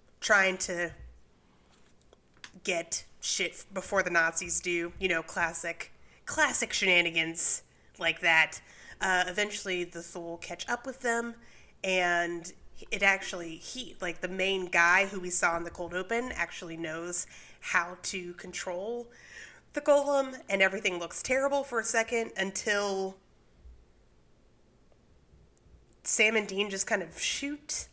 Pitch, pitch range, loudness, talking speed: 185 Hz, 170-210 Hz, -29 LUFS, 130 wpm